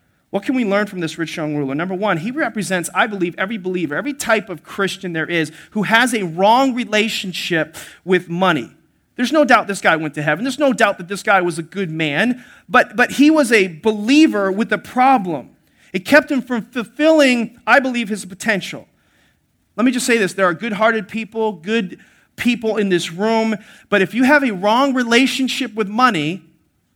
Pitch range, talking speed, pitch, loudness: 180-245 Hz, 200 wpm, 210 Hz, -17 LUFS